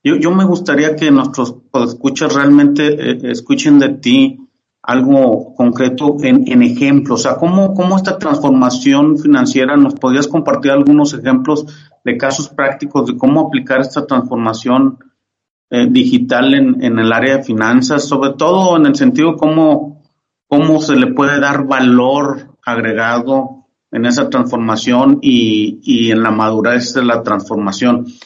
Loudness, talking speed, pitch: -11 LUFS, 150 wpm, 145 Hz